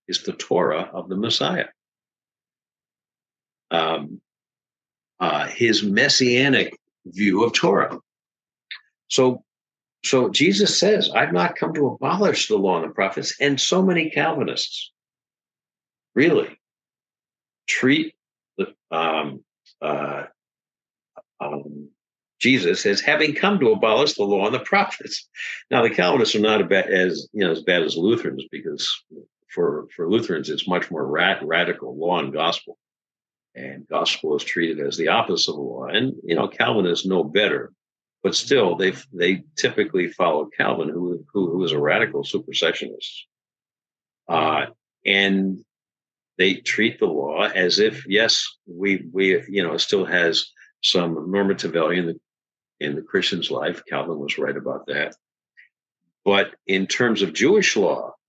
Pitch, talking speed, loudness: 125 Hz, 145 wpm, -21 LUFS